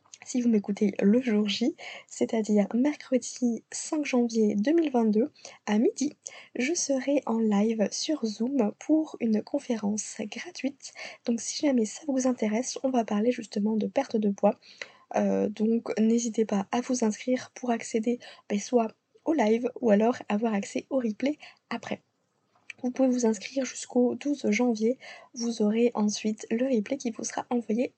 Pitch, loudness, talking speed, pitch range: 235 Hz, -28 LUFS, 155 wpm, 215-260 Hz